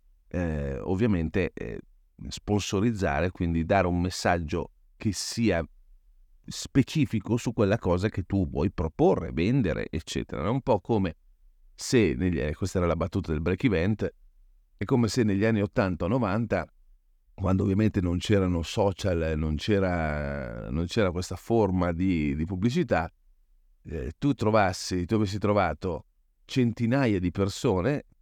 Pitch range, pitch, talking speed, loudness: 85-105 Hz, 95 Hz, 135 wpm, -27 LUFS